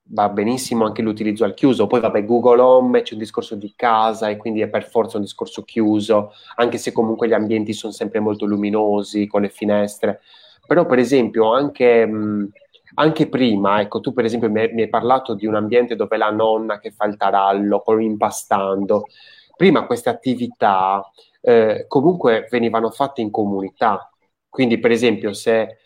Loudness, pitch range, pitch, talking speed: -18 LUFS, 105-120 Hz, 110 Hz, 175 wpm